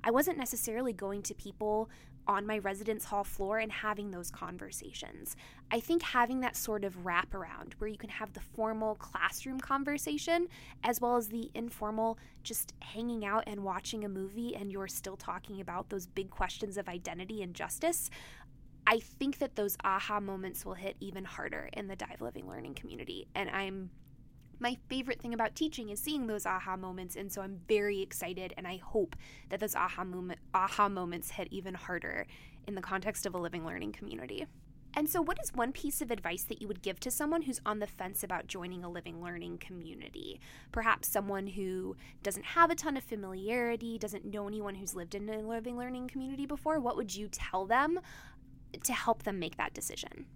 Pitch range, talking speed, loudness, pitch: 190-235 Hz, 195 wpm, -36 LUFS, 205 Hz